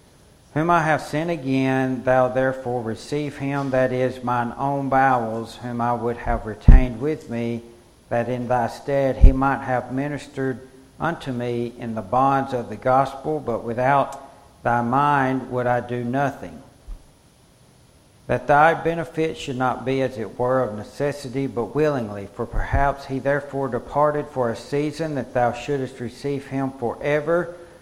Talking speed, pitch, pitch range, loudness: 155 wpm, 130 Hz, 120-140 Hz, -23 LUFS